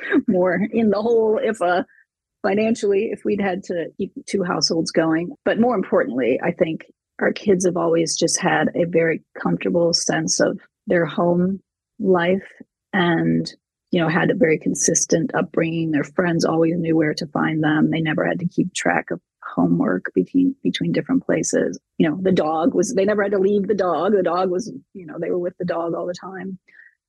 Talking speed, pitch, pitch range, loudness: 195 wpm, 180 Hz, 165-200 Hz, -20 LUFS